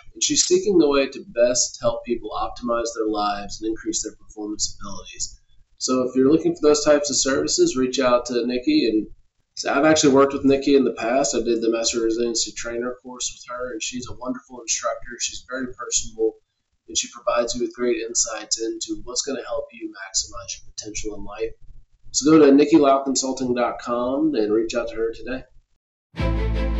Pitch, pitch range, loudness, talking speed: 125 Hz, 115-150 Hz, -21 LUFS, 190 wpm